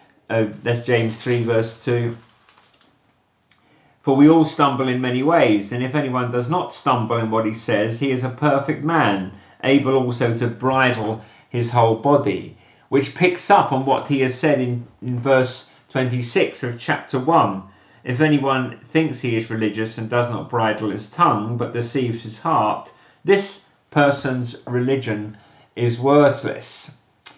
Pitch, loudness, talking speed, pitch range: 125 Hz, -20 LUFS, 155 wpm, 115-140 Hz